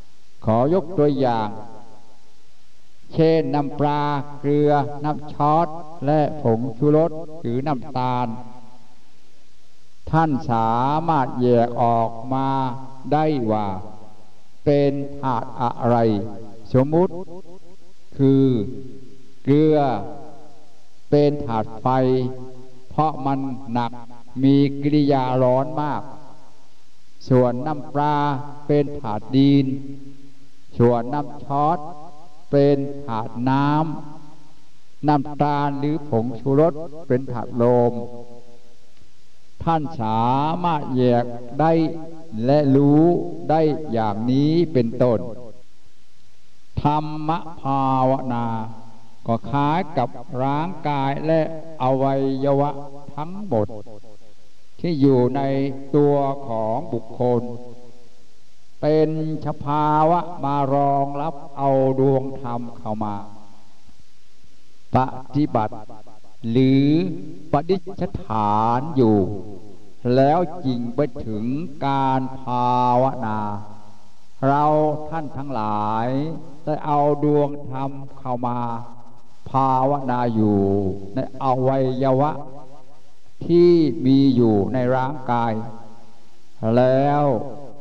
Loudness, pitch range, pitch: -21 LUFS, 120-145 Hz, 135 Hz